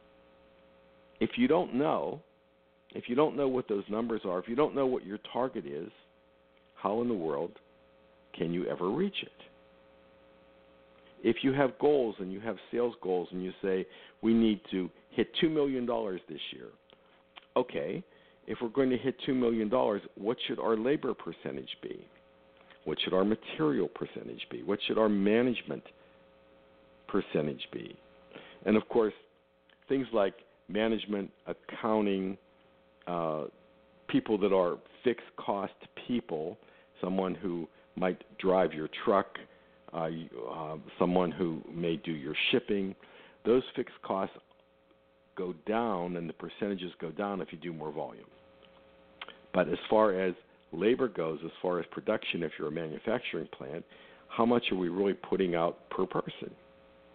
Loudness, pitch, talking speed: -32 LUFS, 85 Hz, 150 wpm